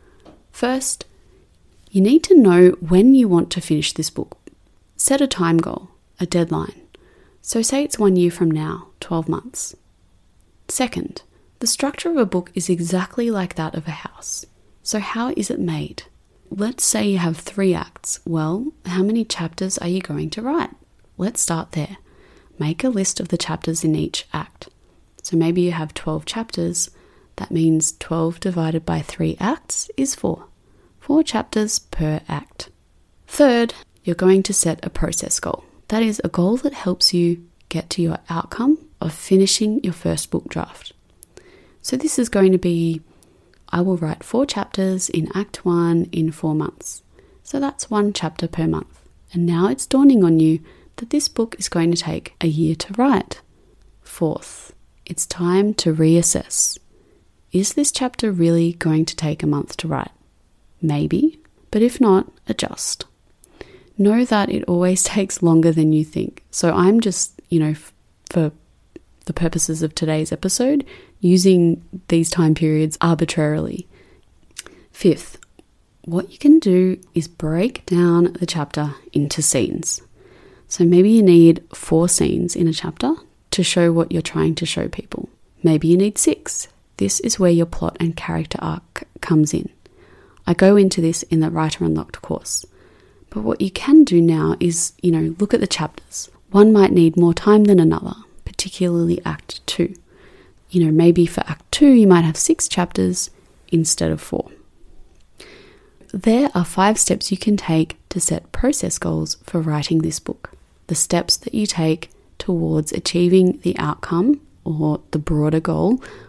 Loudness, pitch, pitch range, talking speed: -18 LUFS, 175 Hz, 160-205 Hz, 165 wpm